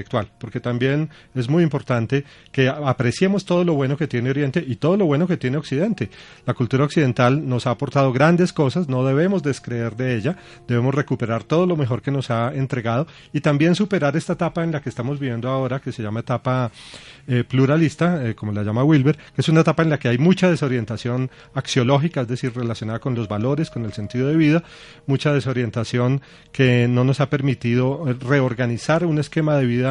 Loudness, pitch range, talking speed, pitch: -20 LUFS, 125-155 Hz, 195 wpm, 135 Hz